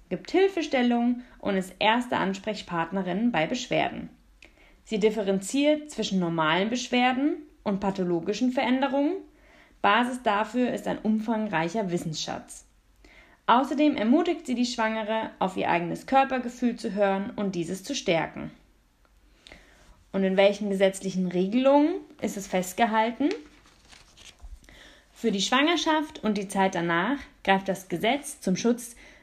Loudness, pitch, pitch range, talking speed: -26 LUFS, 225 Hz, 195-275 Hz, 115 wpm